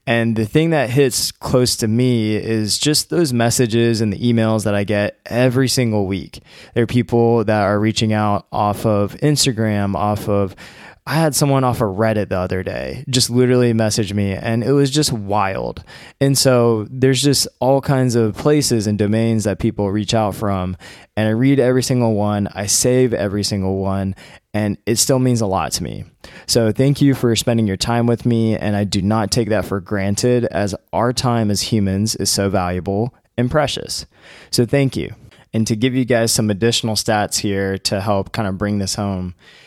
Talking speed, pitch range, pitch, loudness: 200 wpm, 100-125 Hz, 110 Hz, -17 LUFS